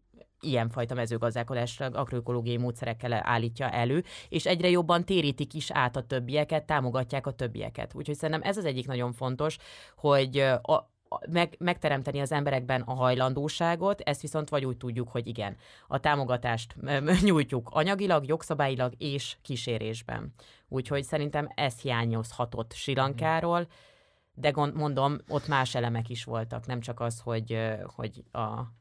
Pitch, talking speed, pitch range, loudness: 135 Hz, 135 wpm, 120-150 Hz, -30 LUFS